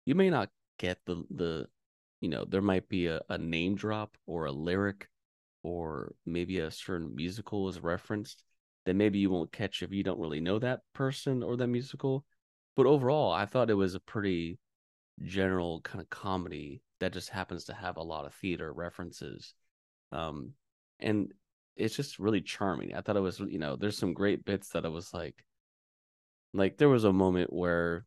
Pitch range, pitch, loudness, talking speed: 85-105 Hz, 95 Hz, -33 LUFS, 190 wpm